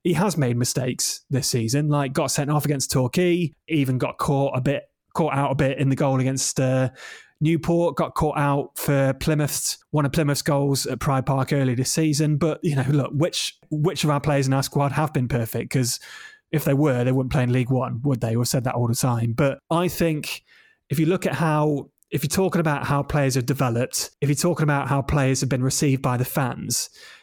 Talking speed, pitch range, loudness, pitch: 225 wpm, 130-155 Hz, -22 LUFS, 140 Hz